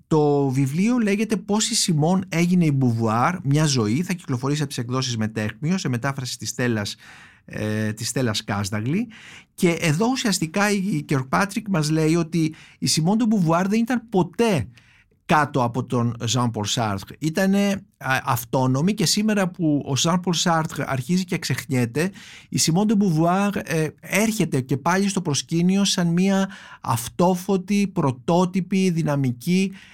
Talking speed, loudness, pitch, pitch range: 145 wpm, -22 LUFS, 160 Hz, 130-190 Hz